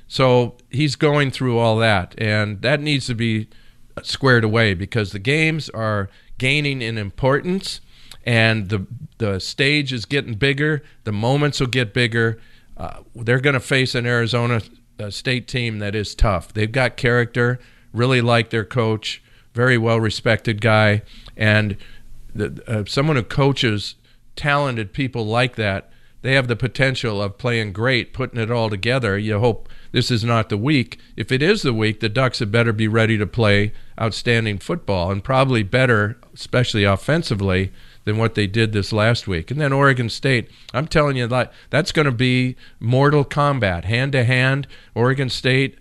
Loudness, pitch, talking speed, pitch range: -19 LUFS, 120 Hz, 170 wpm, 110-130 Hz